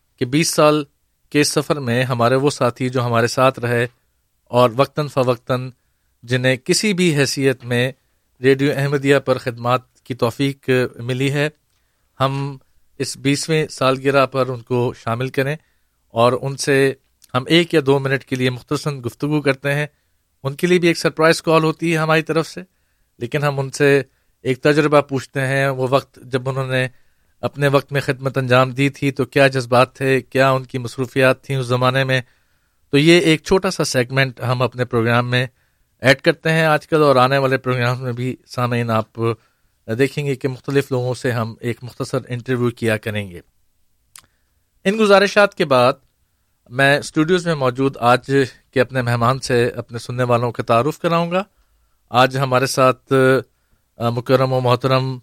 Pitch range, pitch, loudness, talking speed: 120-140 Hz, 130 Hz, -18 LUFS, 170 wpm